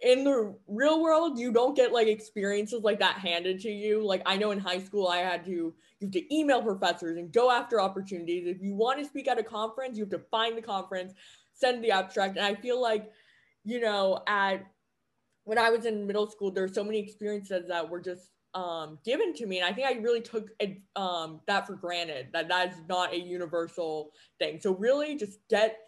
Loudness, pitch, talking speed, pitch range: -29 LUFS, 205 Hz, 220 wpm, 180-230 Hz